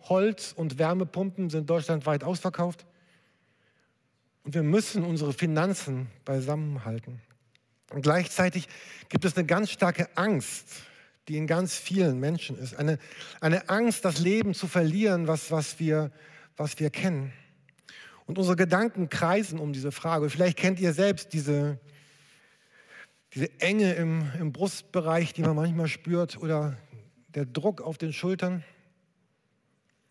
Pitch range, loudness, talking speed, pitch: 150-180 Hz, -28 LUFS, 135 wpm, 165 Hz